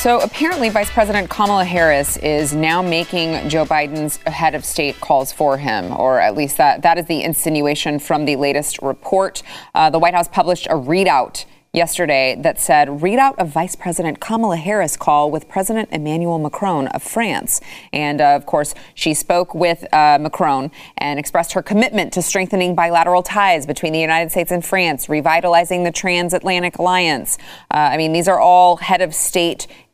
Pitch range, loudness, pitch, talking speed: 155-185 Hz, -16 LUFS, 170 Hz, 175 wpm